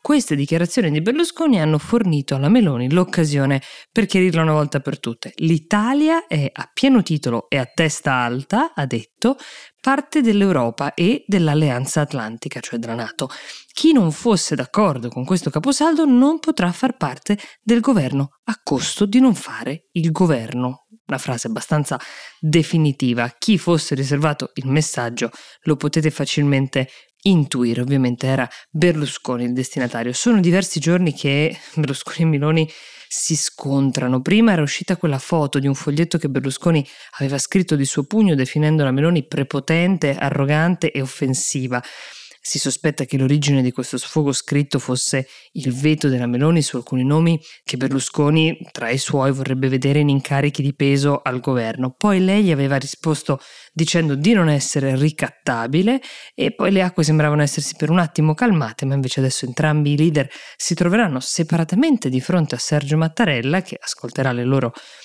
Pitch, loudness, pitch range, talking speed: 150 Hz, -19 LUFS, 135-175 Hz, 155 wpm